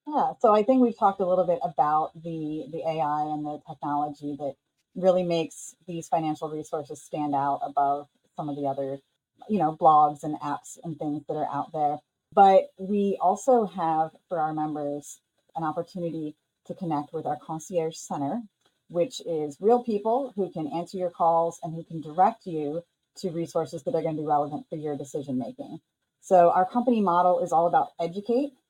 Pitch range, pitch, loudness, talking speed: 150-185 Hz, 165 Hz, -26 LUFS, 185 wpm